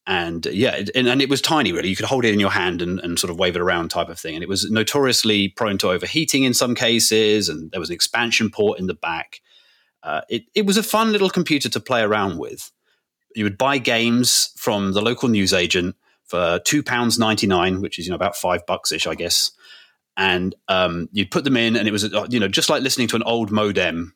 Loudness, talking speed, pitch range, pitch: -19 LUFS, 245 wpm, 100-135 Hz, 115 Hz